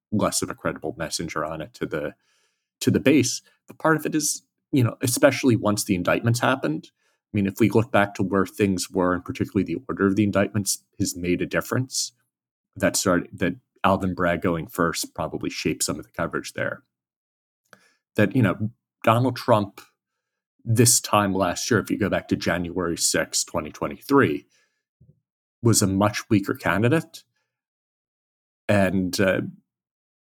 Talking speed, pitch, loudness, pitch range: 165 wpm, 100 Hz, -23 LUFS, 90-115 Hz